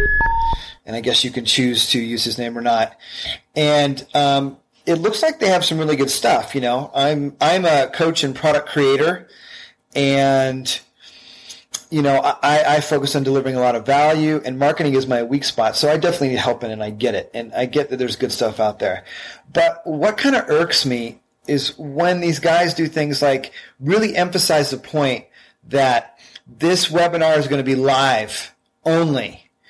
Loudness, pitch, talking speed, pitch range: -18 LUFS, 140 Hz, 190 wpm, 130-160 Hz